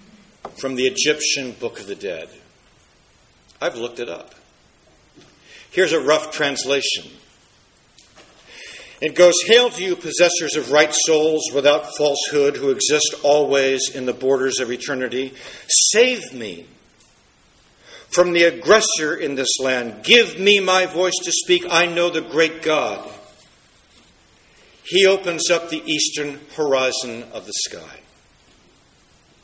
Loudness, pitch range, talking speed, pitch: -17 LUFS, 140-185 Hz, 125 wpm, 155 Hz